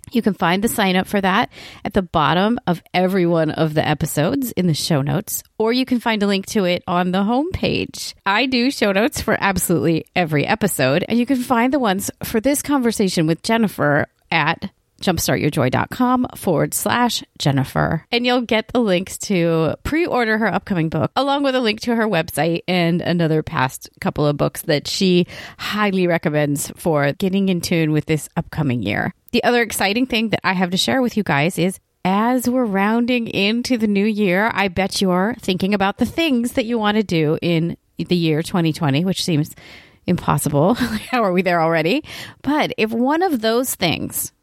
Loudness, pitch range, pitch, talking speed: -19 LUFS, 165-235 Hz, 195 Hz, 195 wpm